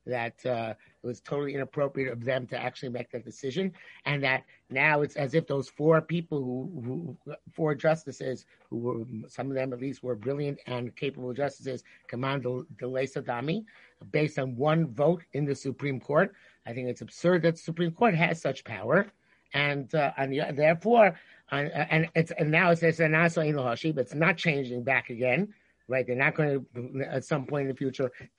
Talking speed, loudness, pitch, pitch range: 190 wpm, -29 LUFS, 140 Hz, 125-160 Hz